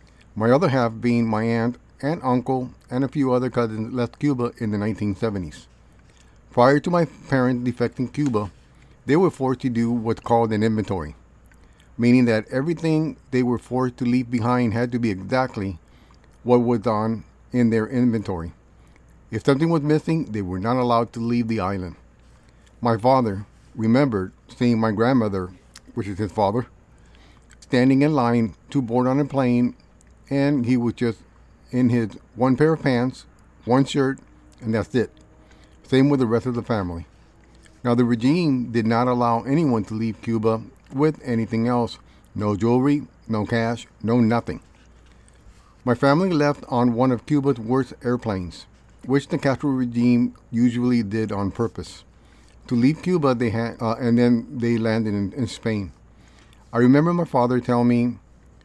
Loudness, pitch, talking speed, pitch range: -22 LUFS, 120 Hz, 165 wpm, 110-130 Hz